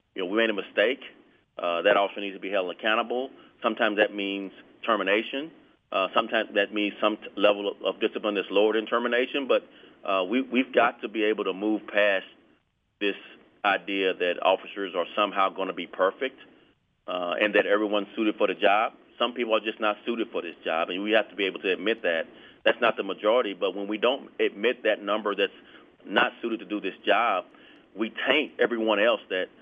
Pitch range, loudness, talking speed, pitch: 100-115 Hz, -26 LUFS, 205 wpm, 105 Hz